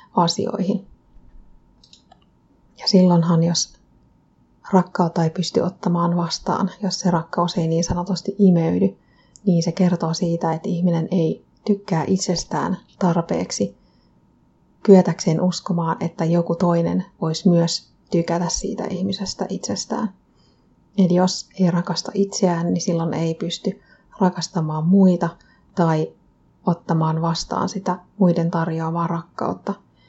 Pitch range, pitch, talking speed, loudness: 165-190 Hz, 175 Hz, 110 wpm, -21 LUFS